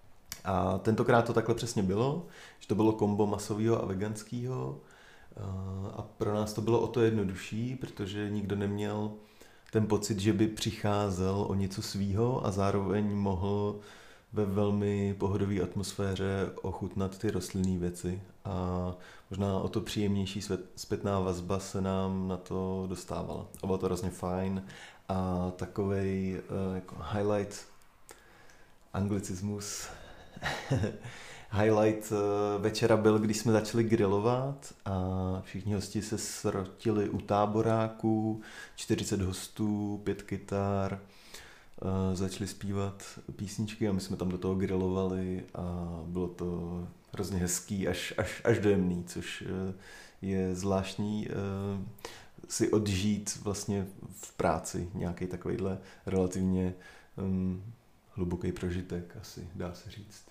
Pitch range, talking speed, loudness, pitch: 95-105 Hz, 120 wpm, -33 LUFS, 100 Hz